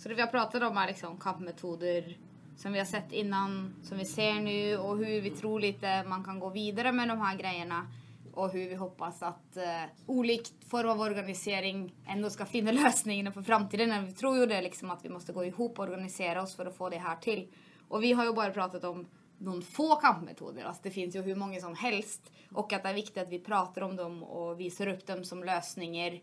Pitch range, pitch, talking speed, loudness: 180-210 Hz, 190 Hz, 230 wpm, -33 LUFS